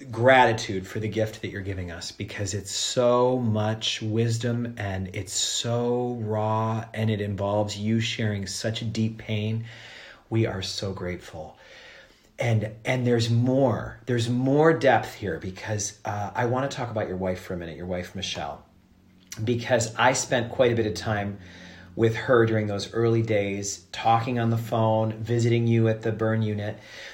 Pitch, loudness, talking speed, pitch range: 110 Hz, -25 LUFS, 170 wpm, 100-115 Hz